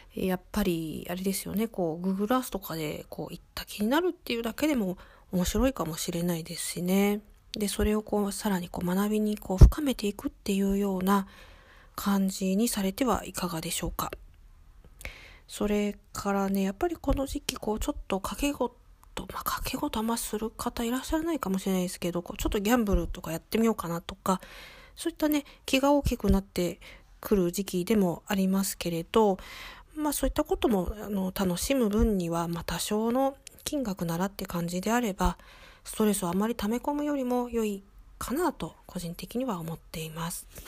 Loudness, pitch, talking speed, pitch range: -29 LUFS, 200 Hz, 380 characters per minute, 180-240 Hz